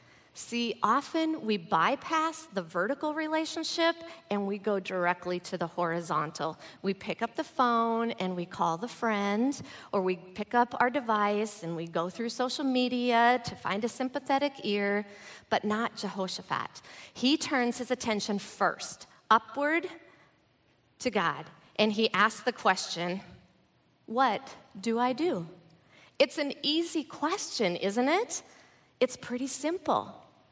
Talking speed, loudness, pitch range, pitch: 140 wpm, -30 LUFS, 195-275 Hz, 230 Hz